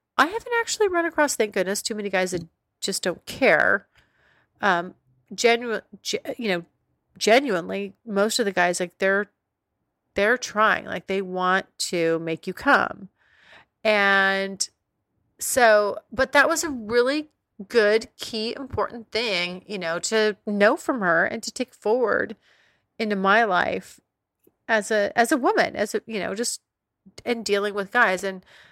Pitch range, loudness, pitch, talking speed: 190-240 Hz, -23 LUFS, 210 Hz, 155 wpm